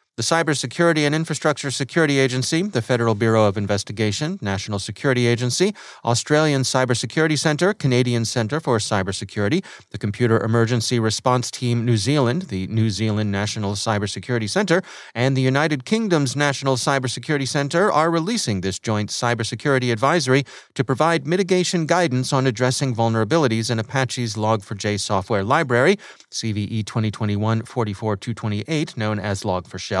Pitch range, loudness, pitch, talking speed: 110-145 Hz, -21 LUFS, 120 Hz, 130 wpm